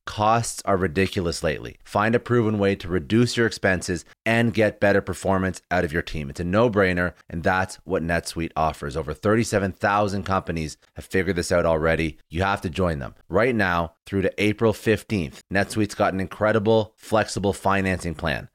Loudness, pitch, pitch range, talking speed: -23 LUFS, 95 Hz, 85-105 Hz, 180 wpm